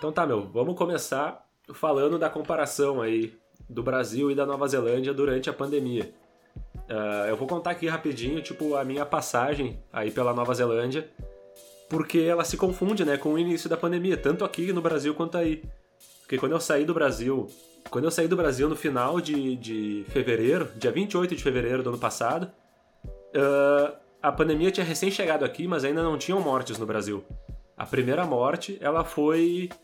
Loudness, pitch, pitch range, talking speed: -27 LUFS, 145 Hz, 125-165 Hz, 175 wpm